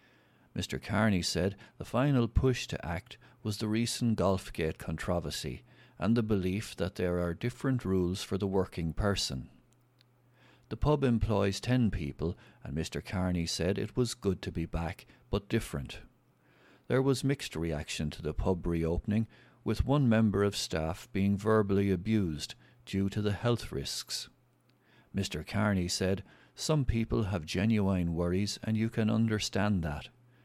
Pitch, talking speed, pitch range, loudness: 100 Hz, 150 wpm, 90-115 Hz, -32 LUFS